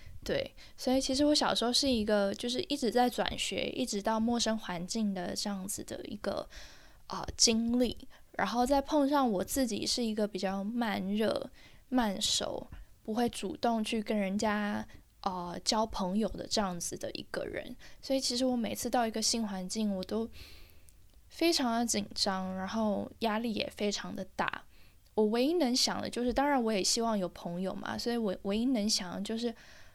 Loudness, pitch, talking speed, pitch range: -32 LUFS, 225 Hz, 265 characters per minute, 200-245 Hz